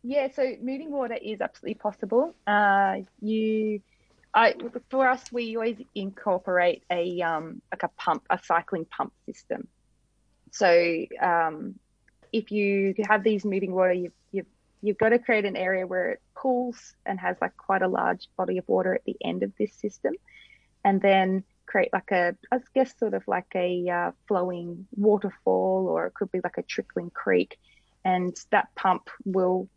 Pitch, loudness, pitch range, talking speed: 200 Hz, -26 LUFS, 180-230 Hz, 170 wpm